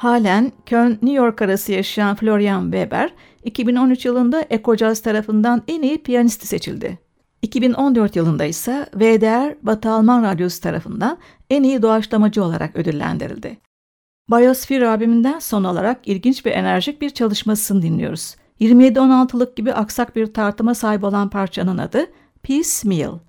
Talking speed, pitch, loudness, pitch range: 130 wpm, 225 Hz, -17 LUFS, 205-250 Hz